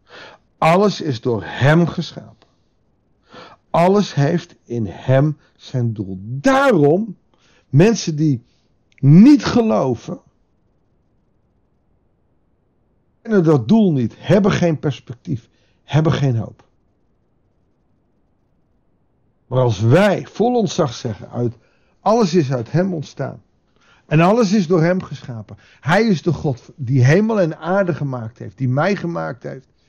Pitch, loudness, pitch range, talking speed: 155 Hz, -17 LUFS, 125-185 Hz, 120 wpm